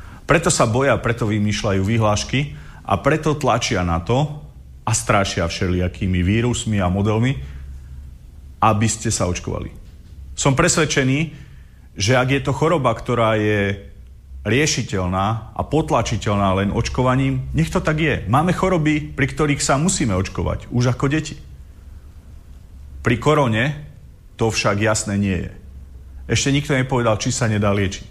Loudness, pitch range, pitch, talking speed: -19 LUFS, 90-140 Hz, 110 Hz, 135 wpm